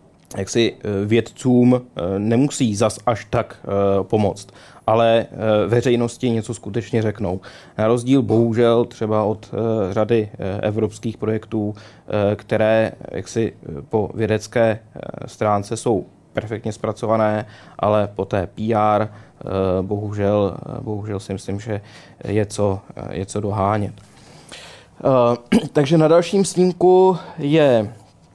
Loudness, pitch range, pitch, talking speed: -20 LUFS, 105-120 Hz, 110 Hz, 105 wpm